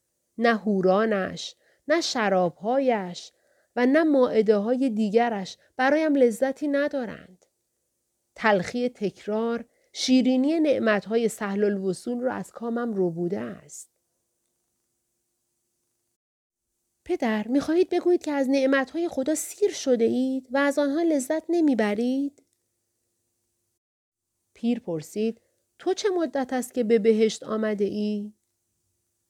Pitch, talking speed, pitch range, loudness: 230 Hz, 105 wpm, 185-270 Hz, -25 LUFS